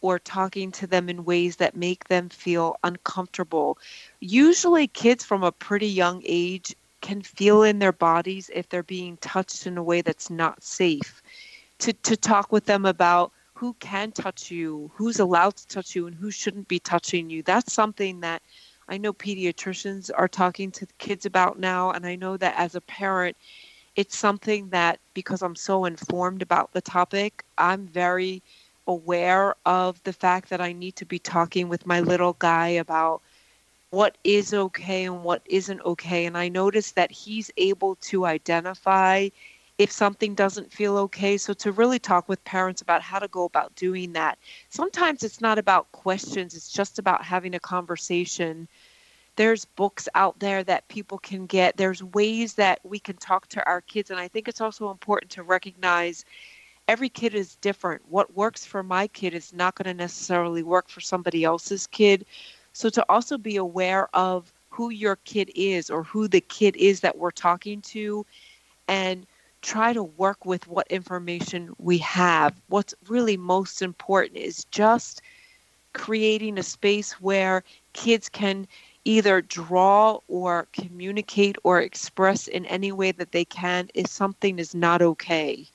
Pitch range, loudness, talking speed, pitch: 180-205 Hz, -24 LUFS, 170 wpm, 190 Hz